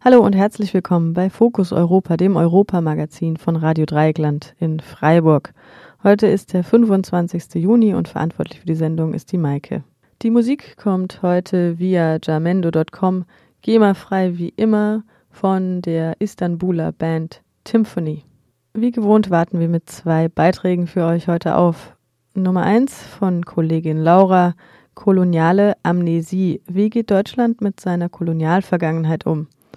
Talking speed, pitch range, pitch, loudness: 135 wpm, 160-195 Hz, 175 Hz, -17 LUFS